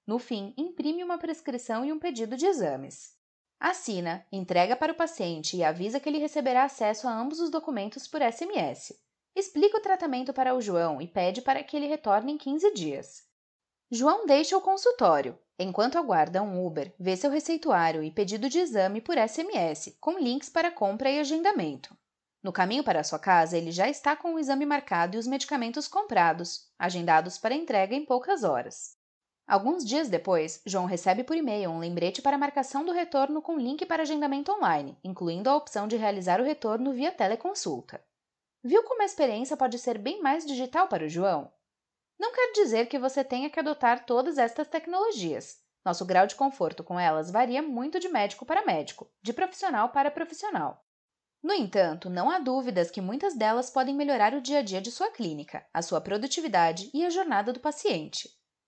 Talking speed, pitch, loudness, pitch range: 185 wpm, 265 Hz, -28 LUFS, 195-310 Hz